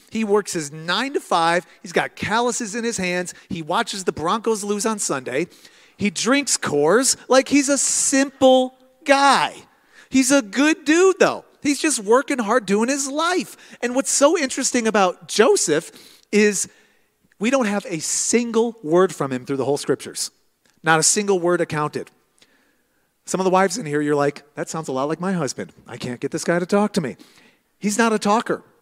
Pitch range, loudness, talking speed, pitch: 175-260 Hz, -20 LUFS, 190 wpm, 210 Hz